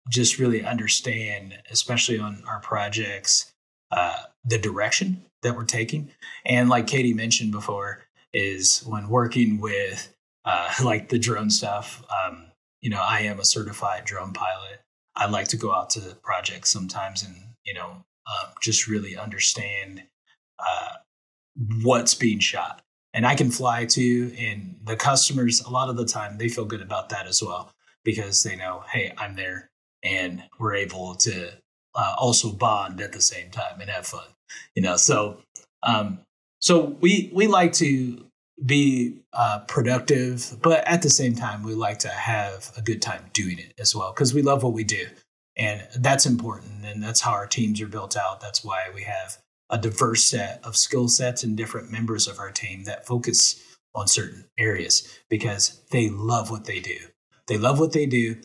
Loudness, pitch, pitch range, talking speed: -23 LUFS, 115 Hz, 105-125 Hz, 175 wpm